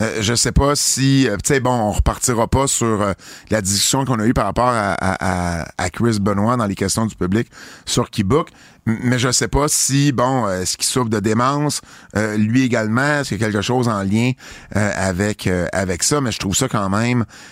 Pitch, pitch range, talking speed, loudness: 115 Hz, 100-130 Hz, 225 wpm, -18 LUFS